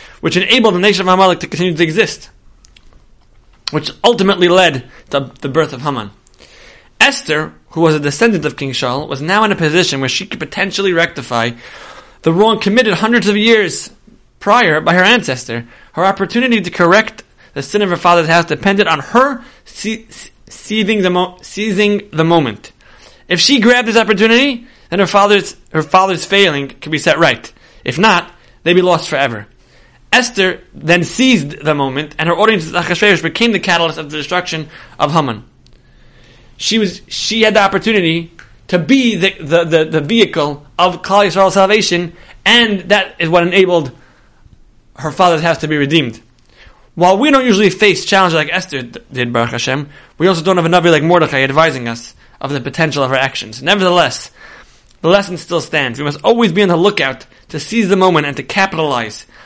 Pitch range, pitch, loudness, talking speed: 145-200 Hz, 175 Hz, -12 LUFS, 180 wpm